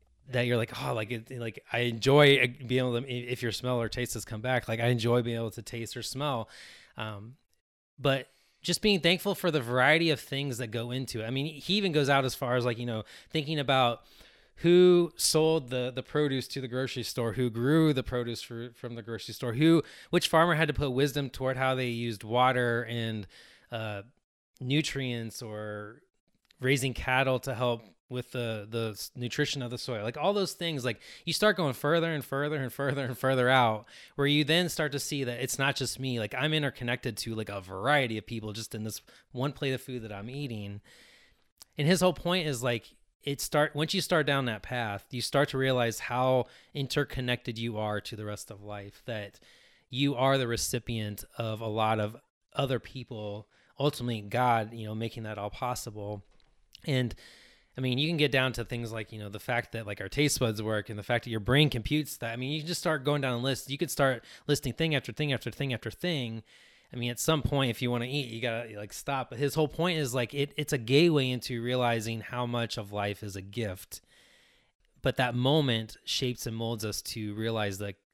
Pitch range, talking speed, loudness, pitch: 115-140 Hz, 220 wpm, -30 LUFS, 125 Hz